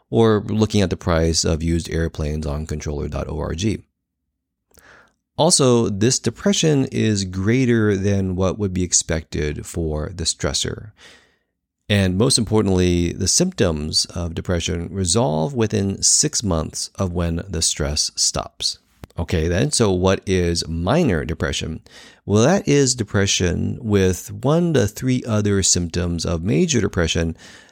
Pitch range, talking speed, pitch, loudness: 85-110 Hz, 130 wpm, 95 Hz, -19 LUFS